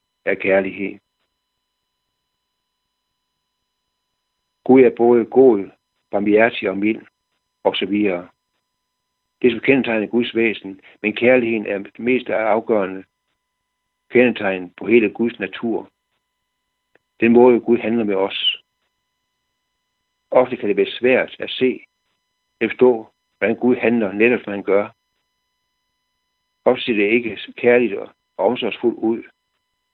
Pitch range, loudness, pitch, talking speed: 100-125 Hz, -18 LUFS, 115 Hz, 115 wpm